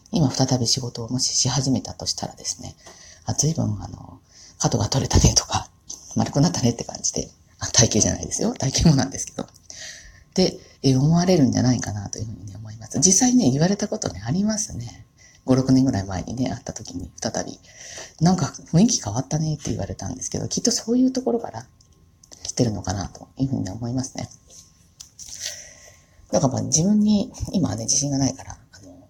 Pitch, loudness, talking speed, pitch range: 125 Hz, -22 LUFS, 380 characters per minute, 105-155 Hz